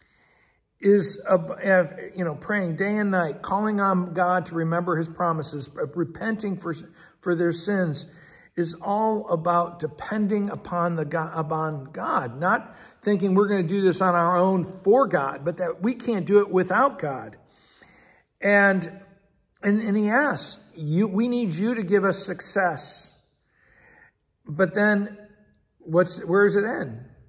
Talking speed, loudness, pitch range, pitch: 150 wpm, -24 LUFS, 170-205 Hz, 185 Hz